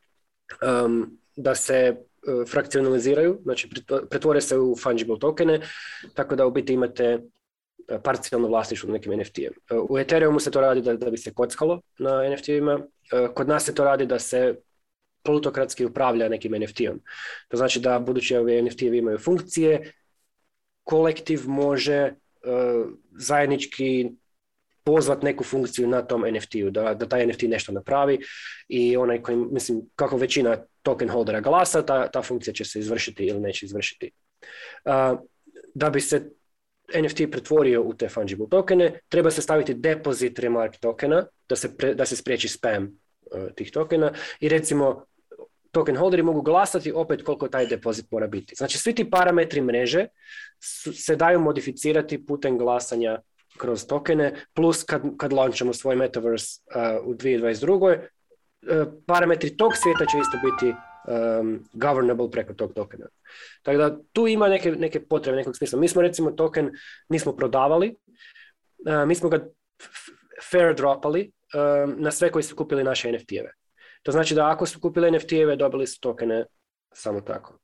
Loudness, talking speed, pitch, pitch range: -23 LUFS, 160 wpm, 140 Hz, 125-160 Hz